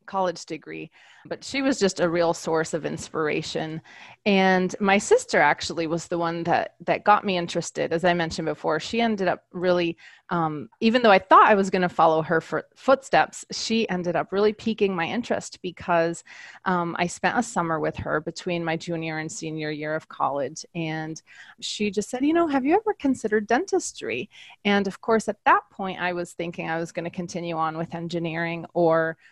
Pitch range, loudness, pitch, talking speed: 165-210 Hz, -24 LUFS, 175 Hz, 195 wpm